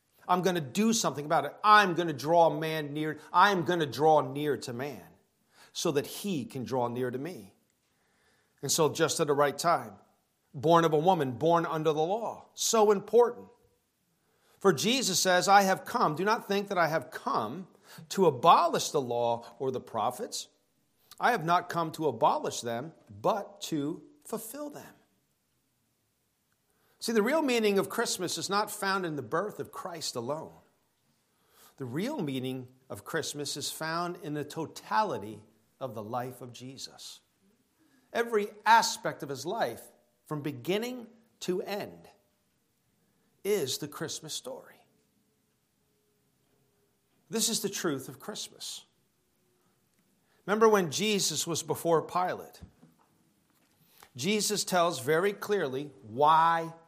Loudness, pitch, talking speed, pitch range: -29 LUFS, 165 Hz, 145 wpm, 145-205 Hz